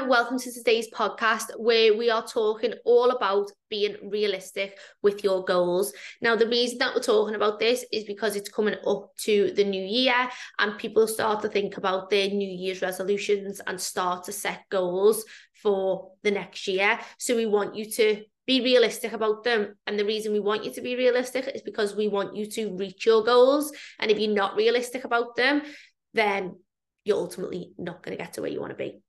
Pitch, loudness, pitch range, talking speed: 215 Hz, -25 LUFS, 200-240 Hz, 200 wpm